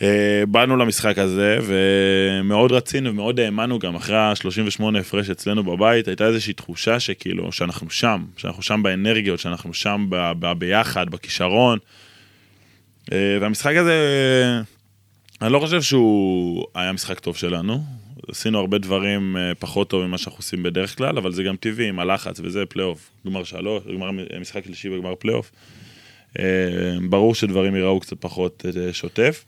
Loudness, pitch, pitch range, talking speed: -20 LUFS, 100 Hz, 95-110 Hz, 140 wpm